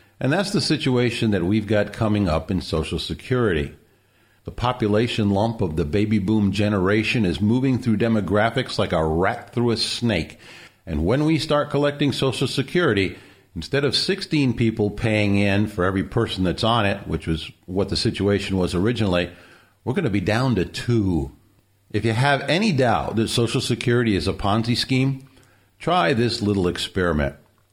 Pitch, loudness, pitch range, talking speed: 110 Hz, -21 LUFS, 95-120 Hz, 170 wpm